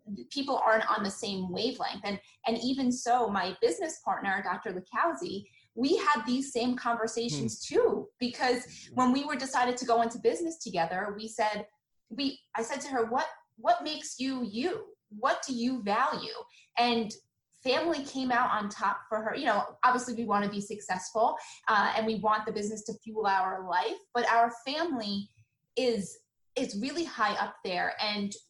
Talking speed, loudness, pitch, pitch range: 175 wpm, -30 LUFS, 235 Hz, 210-265 Hz